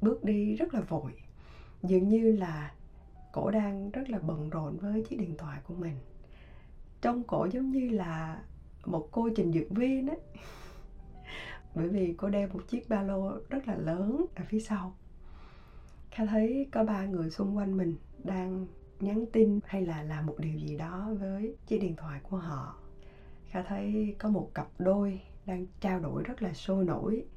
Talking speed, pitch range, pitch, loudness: 180 wpm, 155-215 Hz, 190 Hz, -33 LUFS